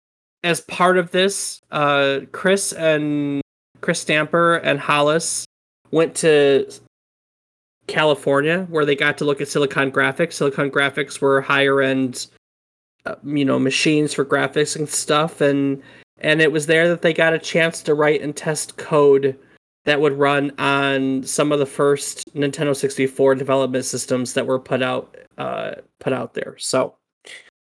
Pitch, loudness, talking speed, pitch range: 145 Hz, -19 LUFS, 155 wpm, 135-160 Hz